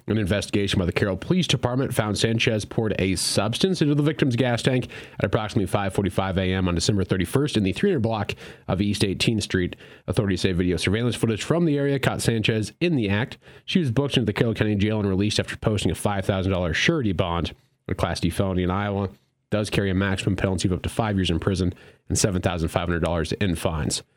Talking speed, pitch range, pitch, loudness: 205 wpm, 95-120 Hz, 105 Hz, -24 LUFS